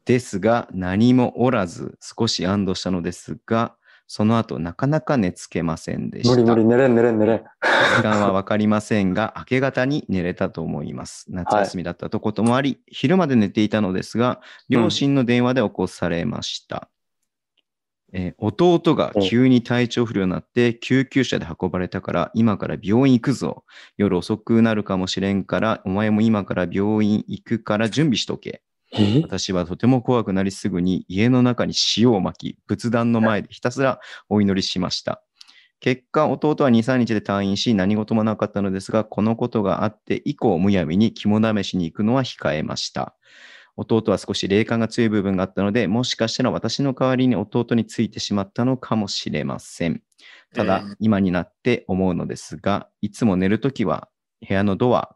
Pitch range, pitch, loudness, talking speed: 95-120 Hz, 110 Hz, -21 LUFS, 345 characters per minute